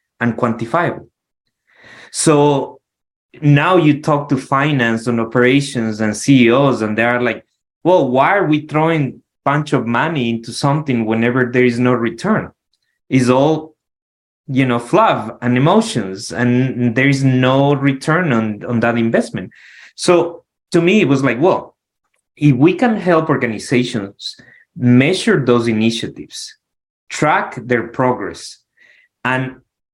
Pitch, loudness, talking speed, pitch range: 125 Hz, -15 LUFS, 130 wpm, 120-145 Hz